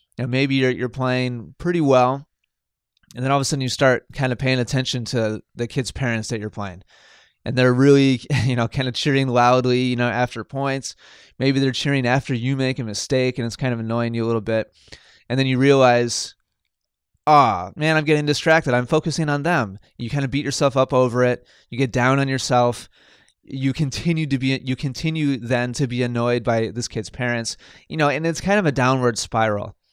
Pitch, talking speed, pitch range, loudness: 130 Hz, 215 wpm, 120-135 Hz, -20 LUFS